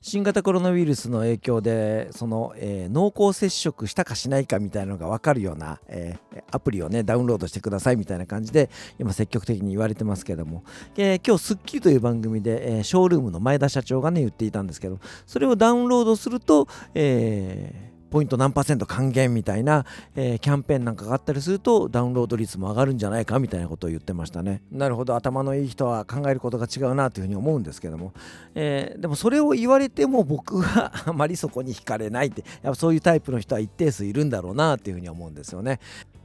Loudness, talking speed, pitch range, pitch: -23 LUFS, 475 characters per minute, 105-150 Hz, 125 Hz